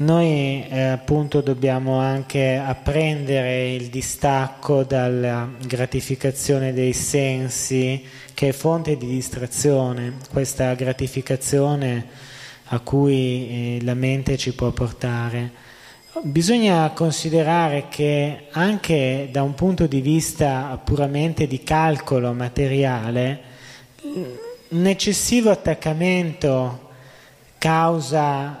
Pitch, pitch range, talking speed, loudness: 135 Hz, 130-150 Hz, 90 wpm, -21 LUFS